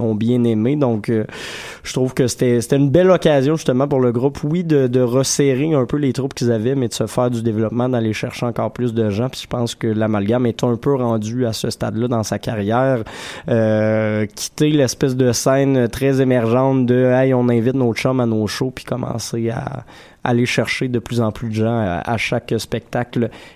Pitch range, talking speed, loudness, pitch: 115-130 Hz, 220 wpm, -18 LUFS, 125 Hz